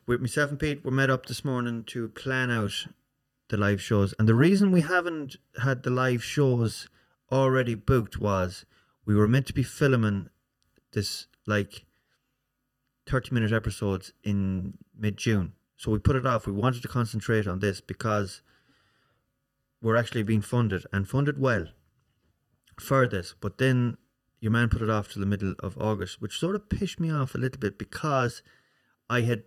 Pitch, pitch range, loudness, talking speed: 120 Hz, 105-130 Hz, -27 LUFS, 175 wpm